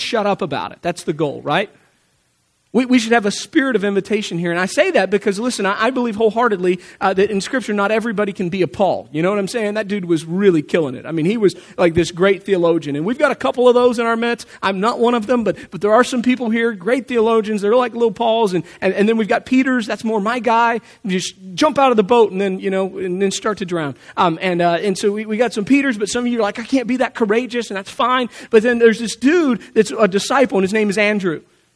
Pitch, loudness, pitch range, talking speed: 215 Hz, -17 LUFS, 190-235 Hz, 280 wpm